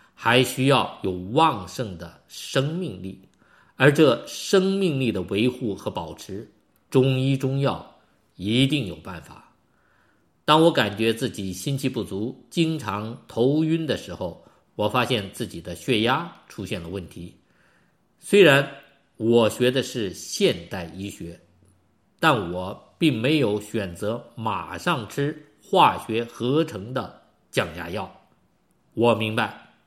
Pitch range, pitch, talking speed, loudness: 100-135 Hz, 115 Hz, 185 characters per minute, -23 LUFS